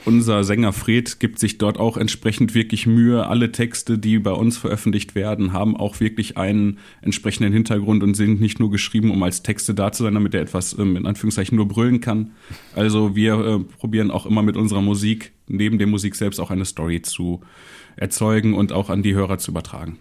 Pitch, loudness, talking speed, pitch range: 105 Hz, -20 LUFS, 200 wpm, 100-110 Hz